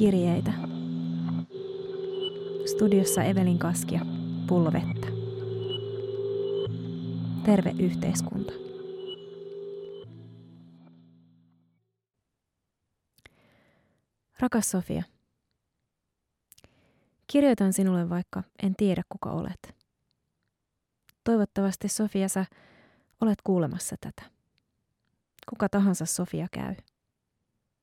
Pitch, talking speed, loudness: 185 Hz, 55 wpm, -28 LUFS